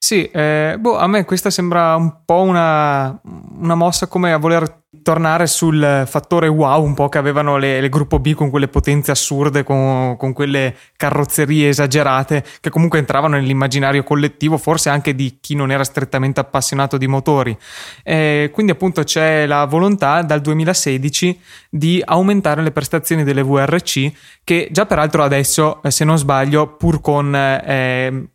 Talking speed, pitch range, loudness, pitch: 160 wpm, 140-165 Hz, -15 LUFS, 150 Hz